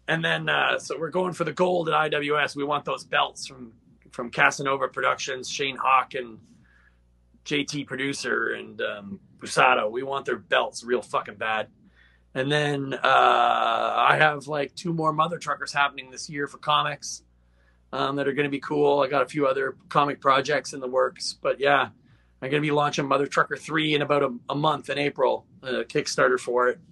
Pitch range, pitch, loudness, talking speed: 125-150 Hz, 140 Hz, -24 LUFS, 195 wpm